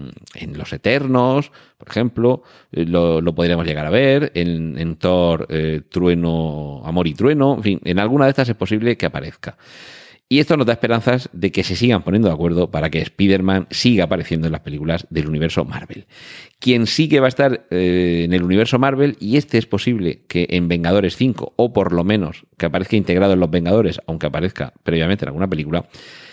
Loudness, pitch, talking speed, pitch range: -18 LUFS, 90 Hz, 200 wpm, 85-120 Hz